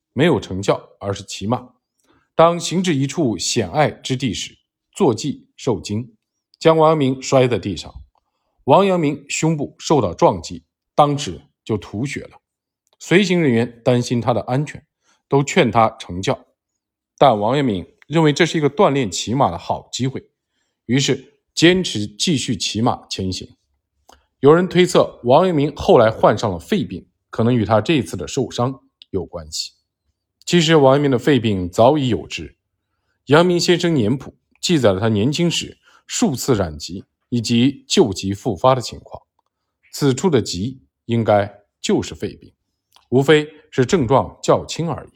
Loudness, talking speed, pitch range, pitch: -18 LUFS, 225 characters per minute, 105-150 Hz, 130 Hz